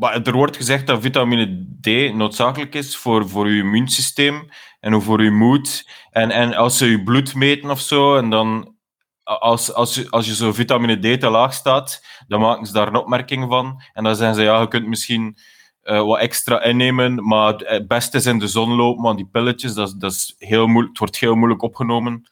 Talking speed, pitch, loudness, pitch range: 210 wpm, 115 Hz, -17 LUFS, 110-125 Hz